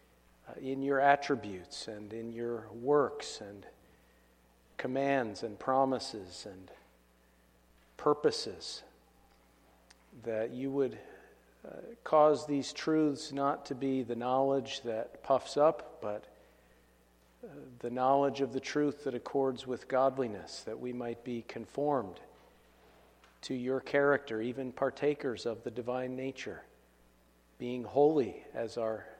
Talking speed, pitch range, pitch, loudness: 115 wpm, 95-135 Hz, 125 Hz, -33 LUFS